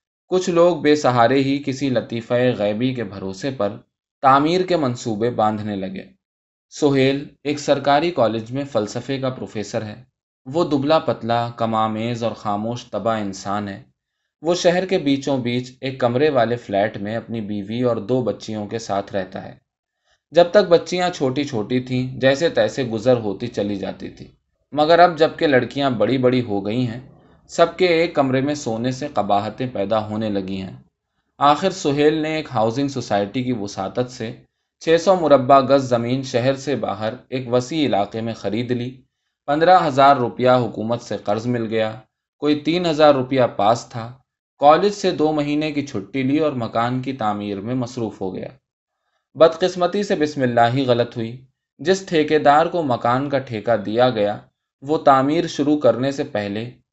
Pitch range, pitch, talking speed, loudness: 110-145 Hz, 125 Hz, 170 wpm, -19 LUFS